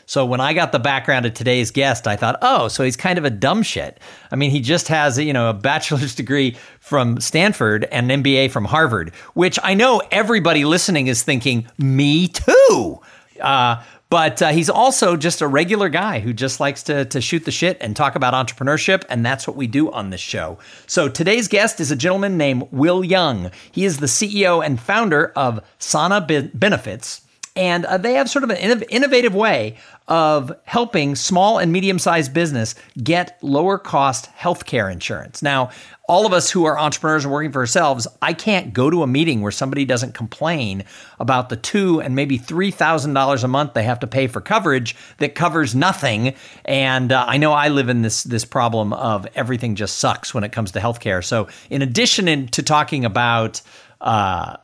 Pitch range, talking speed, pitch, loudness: 125-175 Hz, 195 wpm, 145 Hz, -17 LUFS